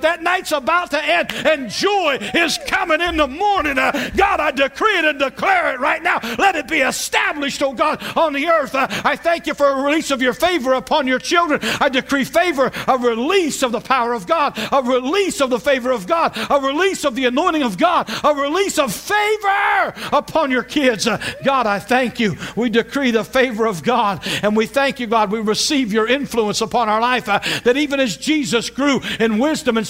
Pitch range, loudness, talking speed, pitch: 240-315 Hz, -17 LUFS, 215 wpm, 275 Hz